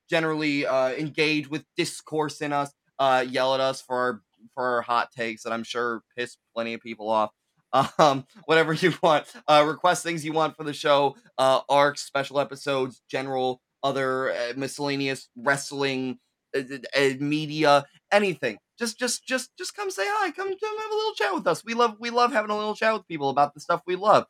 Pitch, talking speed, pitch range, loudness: 145 Hz, 200 wpm, 130-175 Hz, -25 LUFS